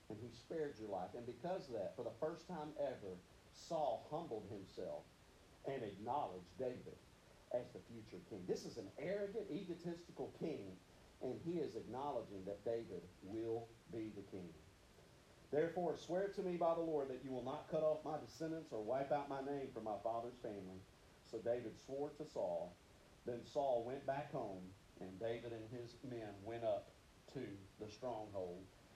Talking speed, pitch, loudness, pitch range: 175 wpm, 120 Hz, -46 LUFS, 105-150 Hz